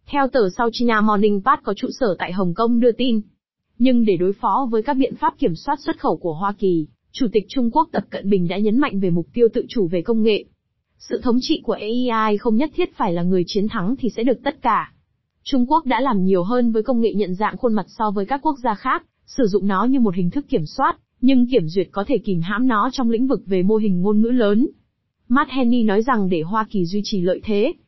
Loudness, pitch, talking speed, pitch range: -20 LUFS, 225 Hz, 260 wpm, 200-255 Hz